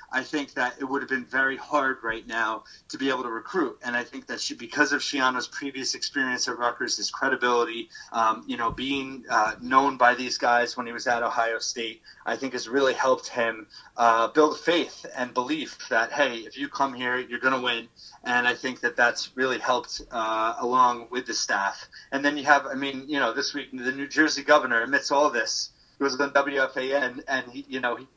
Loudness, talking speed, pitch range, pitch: -25 LUFS, 220 wpm, 120-140 Hz, 130 Hz